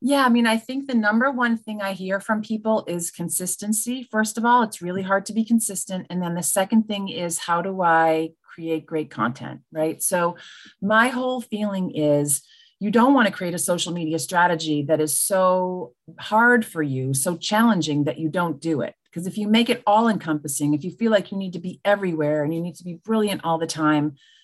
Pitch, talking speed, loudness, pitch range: 180 Hz, 220 wpm, -22 LUFS, 160-220 Hz